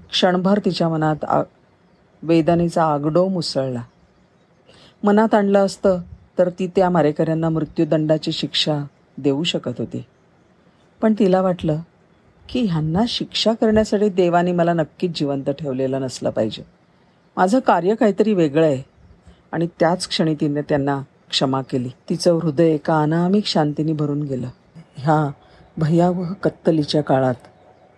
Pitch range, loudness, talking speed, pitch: 150-185 Hz, -19 LUFS, 120 wpm, 165 Hz